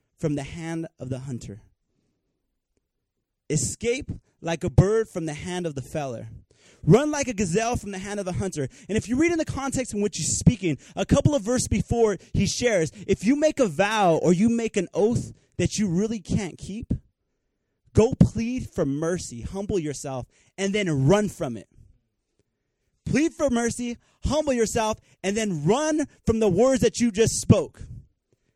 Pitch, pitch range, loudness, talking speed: 195 Hz, 145-230 Hz, -24 LUFS, 180 wpm